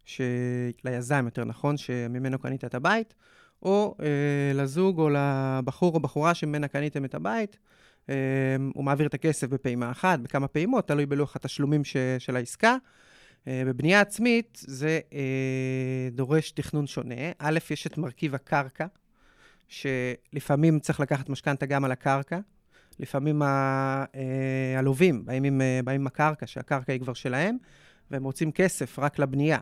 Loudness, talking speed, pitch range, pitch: -27 LUFS, 140 wpm, 130-155 Hz, 140 Hz